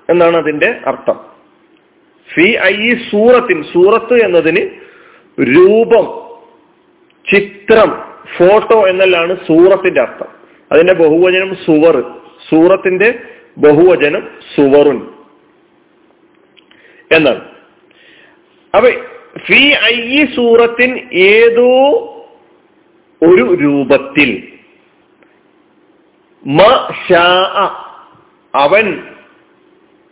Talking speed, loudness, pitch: 55 wpm, -9 LUFS, 250 Hz